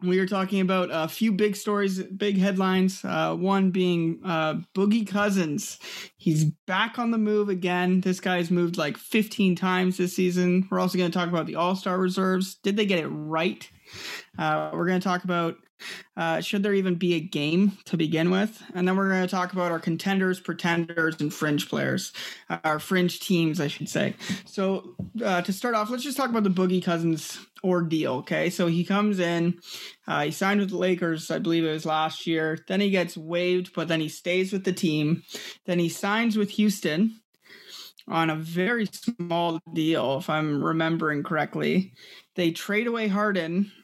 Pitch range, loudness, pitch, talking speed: 165-195 Hz, -26 LUFS, 180 Hz, 190 wpm